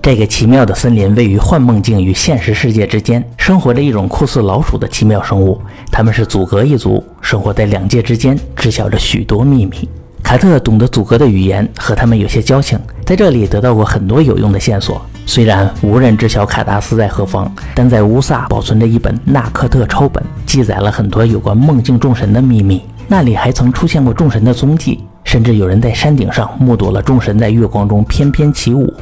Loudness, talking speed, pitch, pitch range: -11 LUFS, 325 characters per minute, 115 Hz, 105-125 Hz